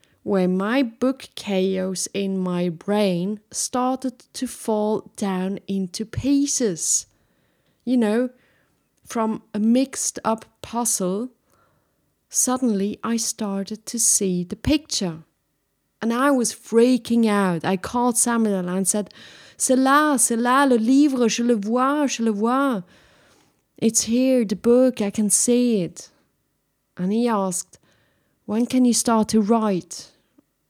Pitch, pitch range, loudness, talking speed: 225 Hz, 195-245 Hz, -21 LUFS, 130 wpm